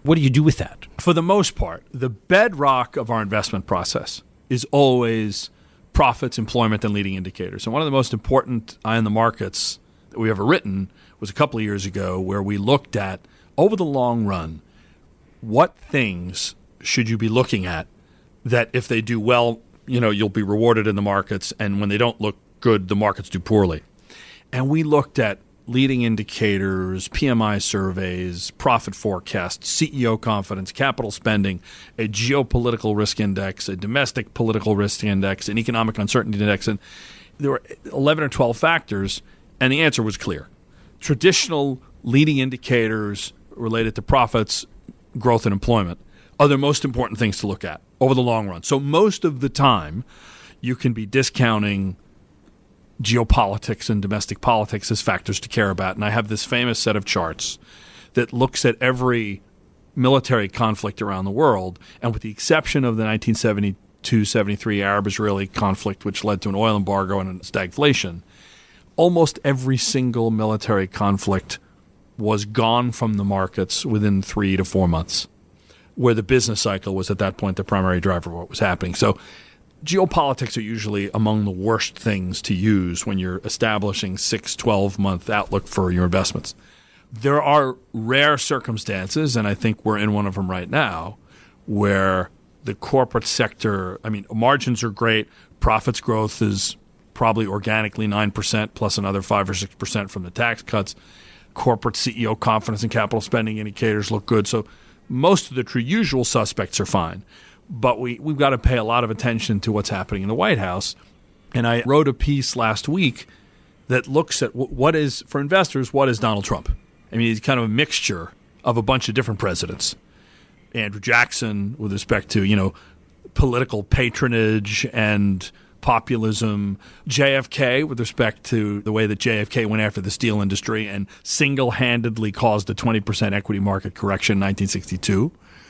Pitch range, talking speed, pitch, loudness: 100-125 Hz, 170 wpm, 110 Hz, -21 LUFS